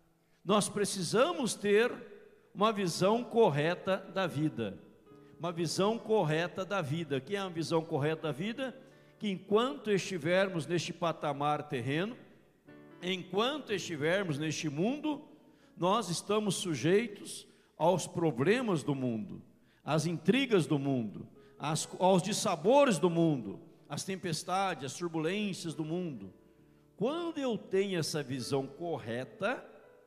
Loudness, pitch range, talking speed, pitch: -32 LUFS, 155-205 Hz, 115 wpm, 175 Hz